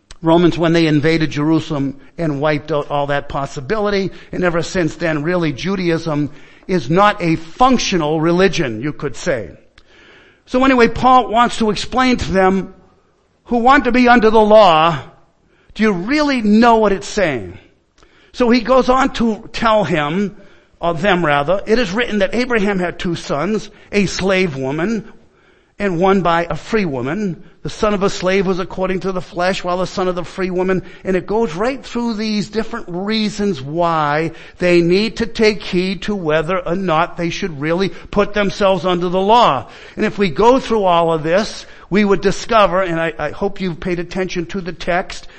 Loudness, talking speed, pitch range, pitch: -16 LUFS, 180 wpm, 170-215 Hz, 190 Hz